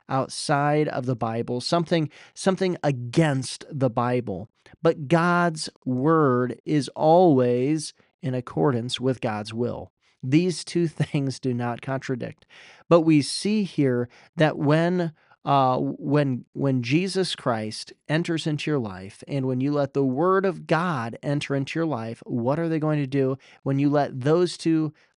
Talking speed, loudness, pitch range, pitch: 150 wpm, -24 LUFS, 125-160 Hz, 145 Hz